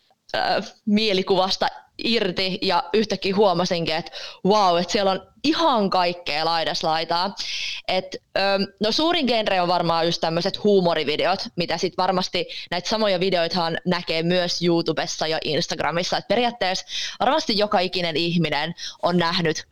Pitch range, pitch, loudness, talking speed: 170-210 Hz, 185 Hz, -22 LUFS, 135 wpm